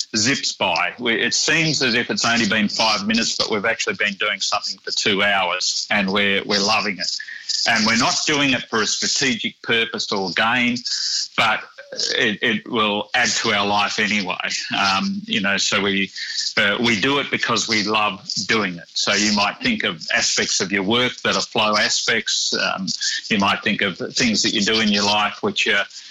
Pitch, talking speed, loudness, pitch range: 115 Hz, 200 wpm, -18 LUFS, 105-135 Hz